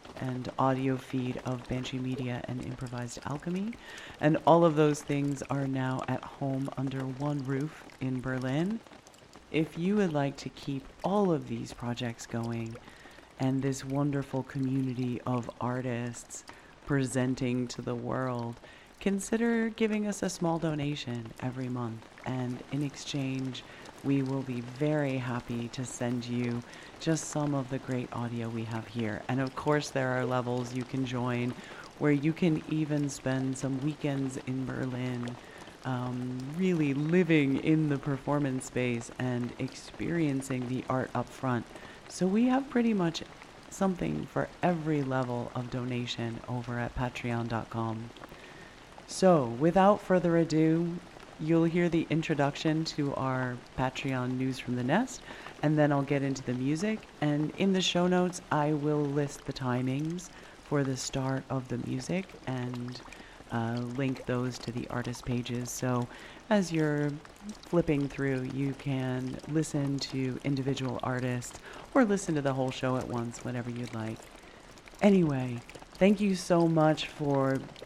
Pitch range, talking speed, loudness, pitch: 125-150 Hz, 145 wpm, -31 LUFS, 135 Hz